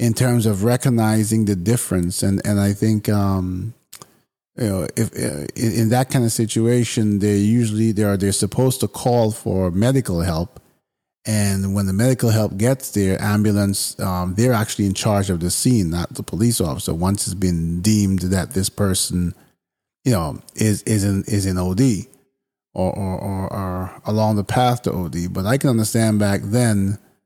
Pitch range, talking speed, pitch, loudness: 95-115 Hz, 180 wpm, 105 Hz, -19 LUFS